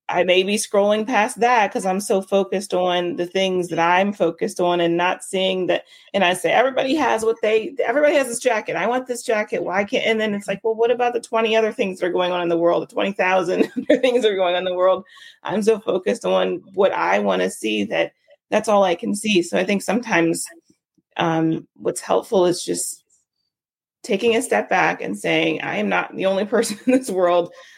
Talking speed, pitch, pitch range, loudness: 225 wpm, 190 Hz, 175-225 Hz, -20 LUFS